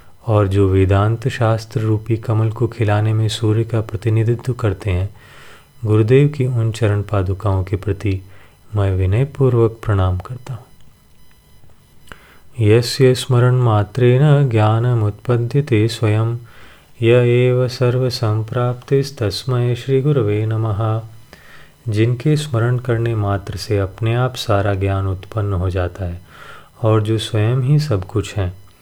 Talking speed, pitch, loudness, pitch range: 125 wpm, 110 Hz, -17 LUFS, 105-125 Hz